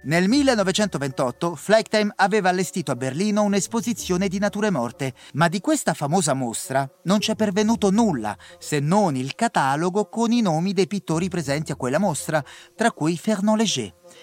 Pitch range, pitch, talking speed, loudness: 155-210 Hz, 195 Hz, 155 wpm, -22 LUFS